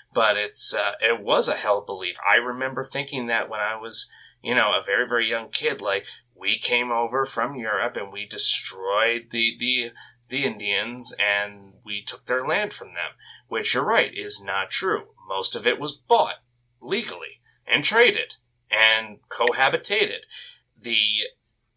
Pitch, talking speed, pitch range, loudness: 115 Hz, 170 wpm, 105-125 Hz, -23 LUFS